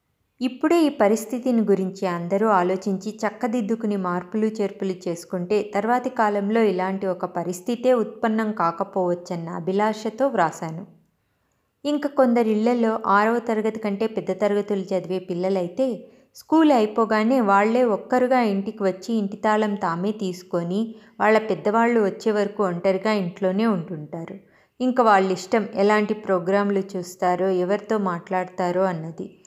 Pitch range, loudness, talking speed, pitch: 185-225 Hz, -22 LUFS, 110 wpm, 205 Hz